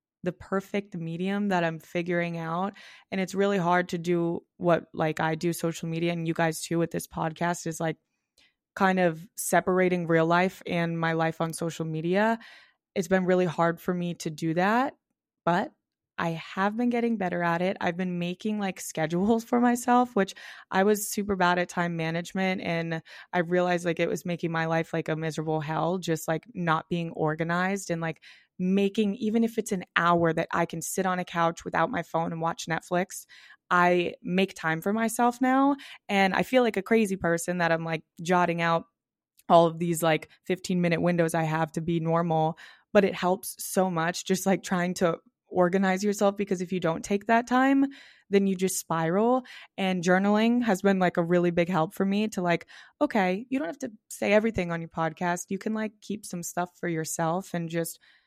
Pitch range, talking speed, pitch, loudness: 165-200 Hz, 200 wpm, 180 Hz, -27 LUFS